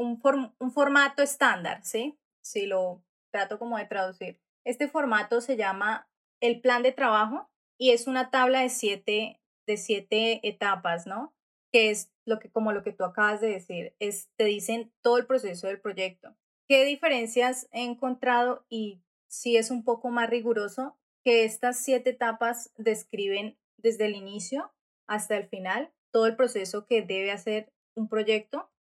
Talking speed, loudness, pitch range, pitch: 170 wpm, -27 LUFS, 210-255 Hz, 230 Hz